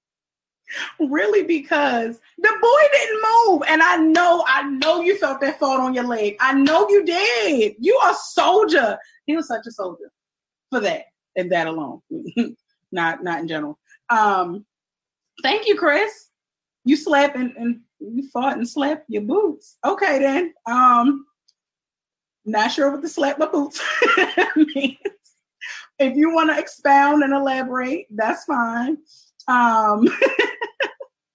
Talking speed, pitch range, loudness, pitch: 145 wpm, 245-345 Hz, -19 LUFS, 290 Hz